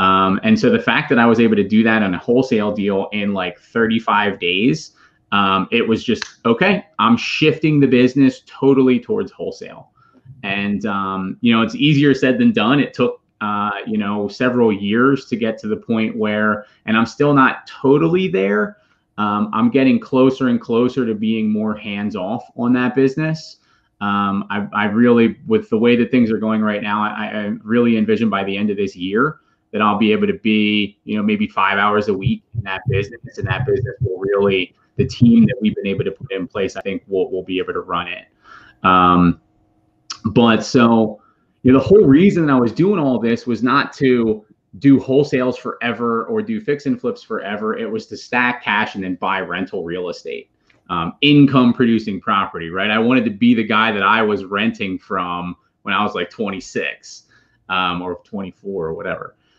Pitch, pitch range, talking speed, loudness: 115 Hz, 105-135 Hz, 200 wpm, -17 LUFS